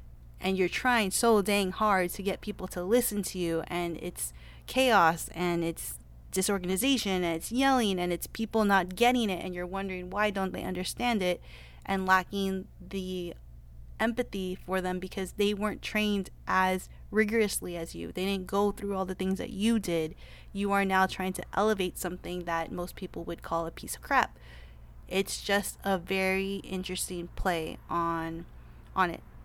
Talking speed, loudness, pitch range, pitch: 175 wpm, -30 LUFS, 170-200 Hz, 185 Hz